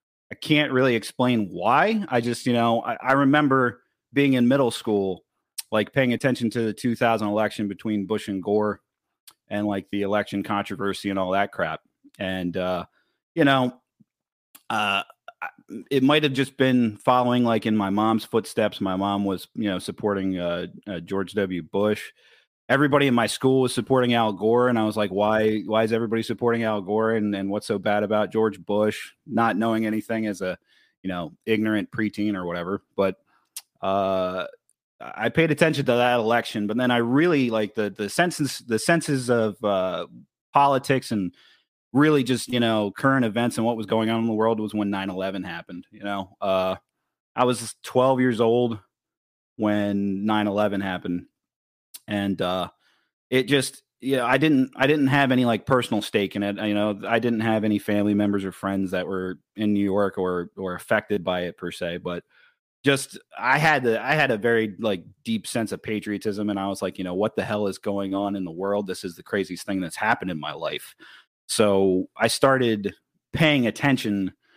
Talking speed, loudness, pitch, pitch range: 190 wpm, -23 LUFS, 110 Hz, 100-125 Hz